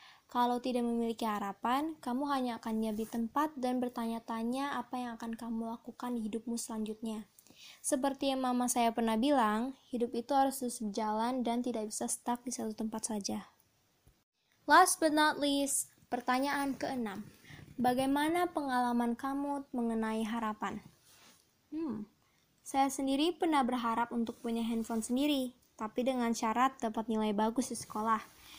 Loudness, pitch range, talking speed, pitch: -34 LUFS, 225-270 Hz, 140 wpm, 240 Hz